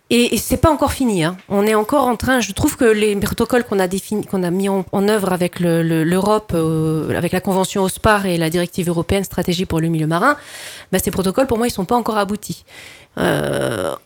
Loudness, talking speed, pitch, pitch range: -17 LUFS, 230 wpm, 195 Hz, 175-220 Hz